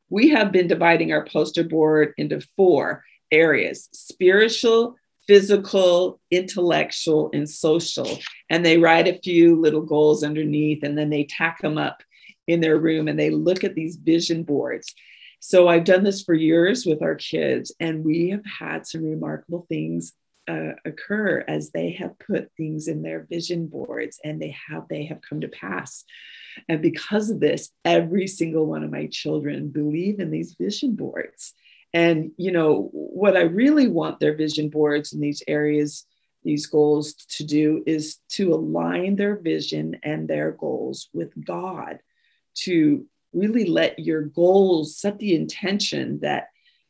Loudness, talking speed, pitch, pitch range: -21 LUFS, 160 wpm, 165 Hz, 155-200 Hz